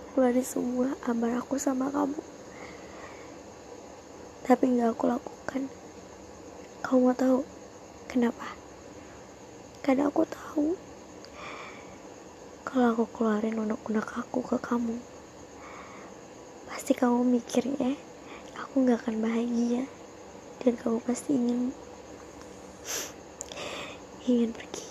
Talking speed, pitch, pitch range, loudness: 95 wpm, 250 Hz, 240-270 Hz, -29 LUFS